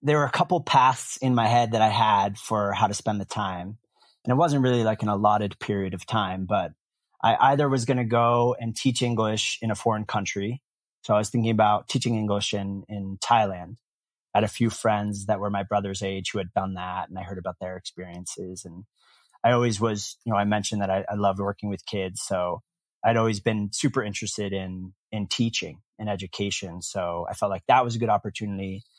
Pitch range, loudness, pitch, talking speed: 100-115 Hz, -25 LUFS, 105 Hz, 215 wpm